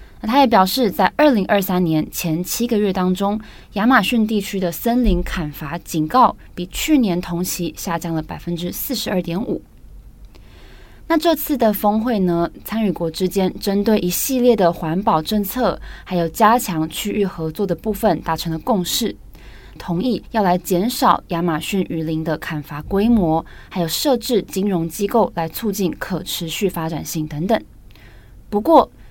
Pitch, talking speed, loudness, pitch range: 185 Hz, 245 characters per minute, -19 LUFS, 170-220 Hz